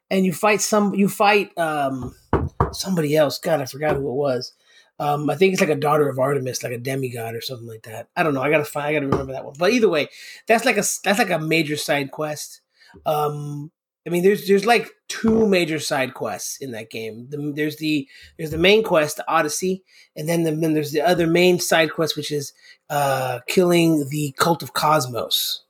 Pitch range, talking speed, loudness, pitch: 140-180 Hz, 220 wpm, -20 LUFS, 155 Hz